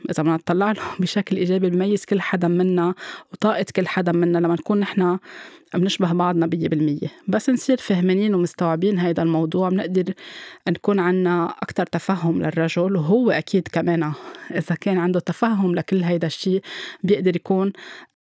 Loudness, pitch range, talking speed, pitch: -21 LUFS, 170-195 Hz, 150 wpm, 180 Hz